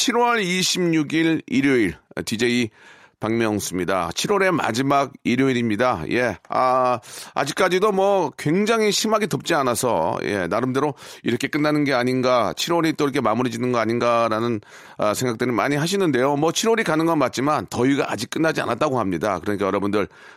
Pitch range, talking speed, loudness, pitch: 120-170 Hz, 350 characters per minute, -21 LUFS, 135 Hz